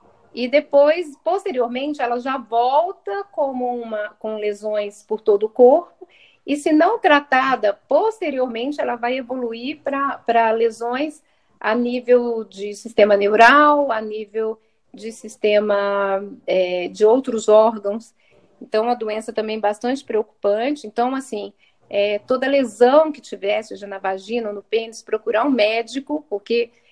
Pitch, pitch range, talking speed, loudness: 235 Hz, 215-275 Hz, 135 wpm, -19 LUFS